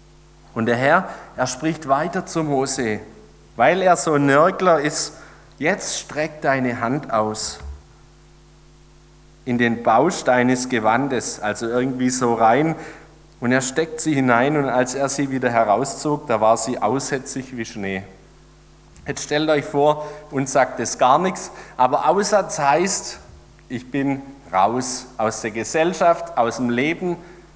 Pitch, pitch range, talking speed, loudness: 140 Hz, 120-160 Hz, 145 wpm, -20 LUFS